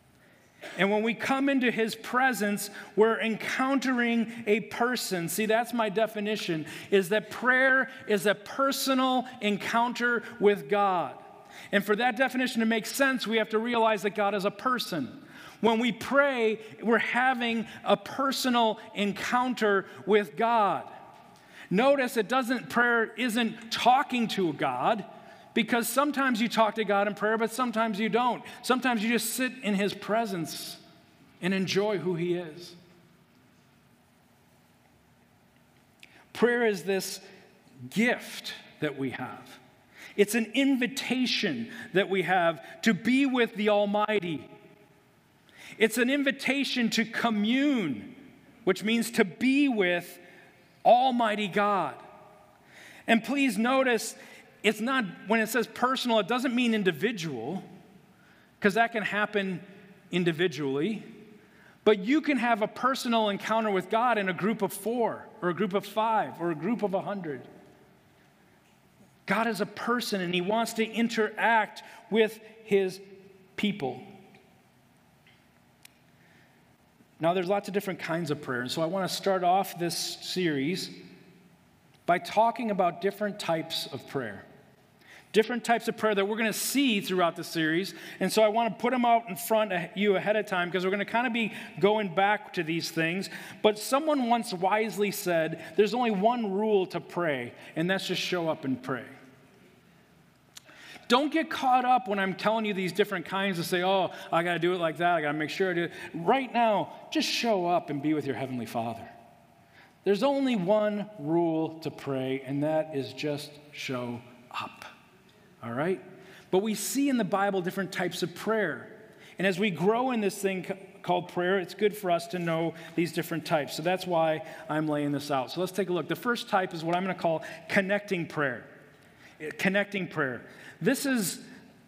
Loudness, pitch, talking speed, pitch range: -28 LUFS, 205 Hz, 165 wpm, 180-230 Hz